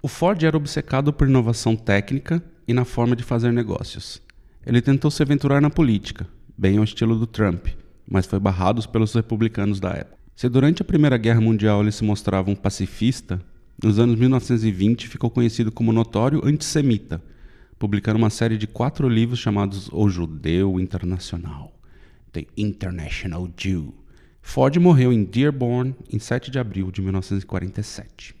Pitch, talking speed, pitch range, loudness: 110 Hz, 155 wpm, 95-125 Hz, -21 LUFS